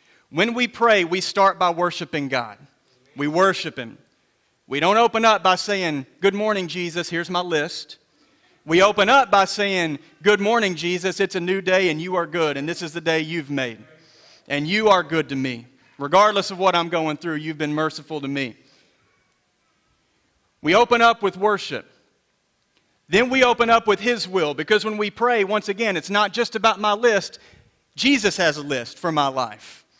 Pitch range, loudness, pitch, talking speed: 155-210 Hz, -20 LUFS, 180 Hz, 190 wpm